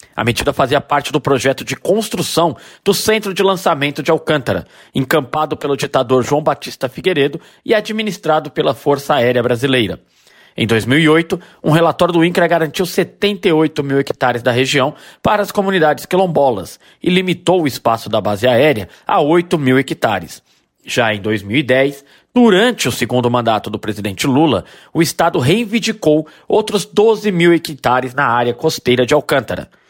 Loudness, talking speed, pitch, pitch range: -15 LUFS, 150 wpm, 150 Hz, 130-175 Hz